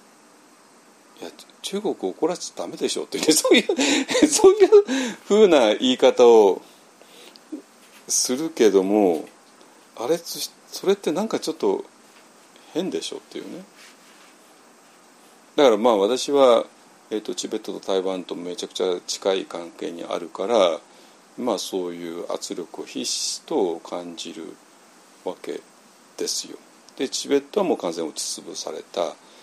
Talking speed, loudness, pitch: 270 characters per minute, -21 LUFS, 265 Hz